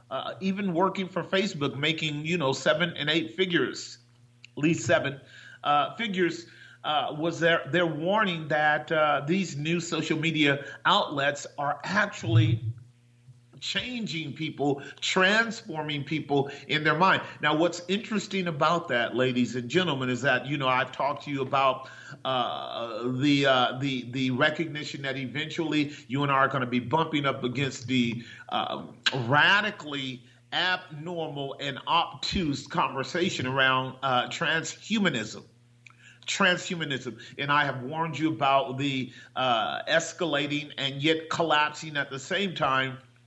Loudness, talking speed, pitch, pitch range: -27 LUFS, 140 wpm, 145 Hz, 130-165 Hz